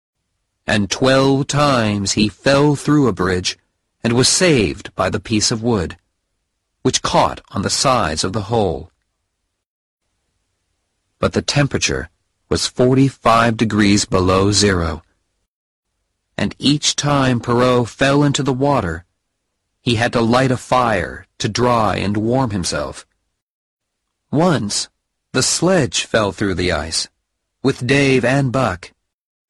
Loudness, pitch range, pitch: -16 LUFS, 95-125 Hz, 105 Hz